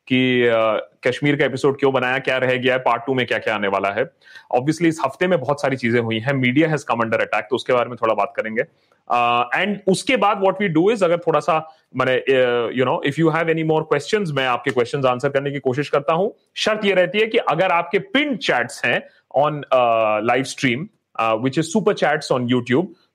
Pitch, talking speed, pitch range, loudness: 140 Hz, 225 wpm, 125-170 Hz, -19 LUFS